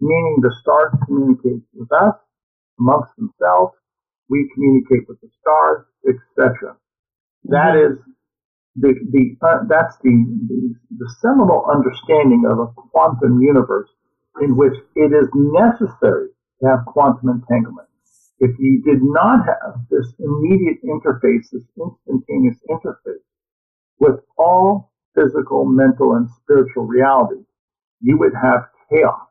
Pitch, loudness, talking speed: 145 Hz, -15 LUFS, 125 wpm